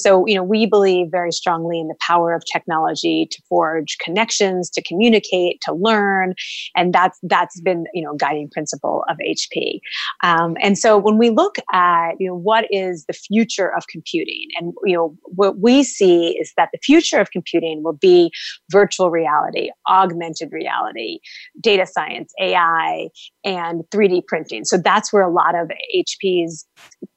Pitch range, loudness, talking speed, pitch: 170-215 Hz, -17 LUFS, 170 wpm, 185 Hz